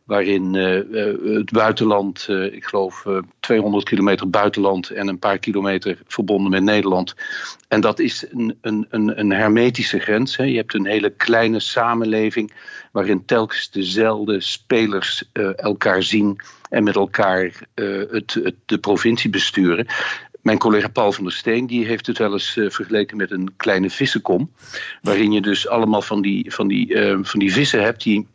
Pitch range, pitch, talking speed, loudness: 100-110 Hz, 105 Hz, 170 wpm, -19 LUFS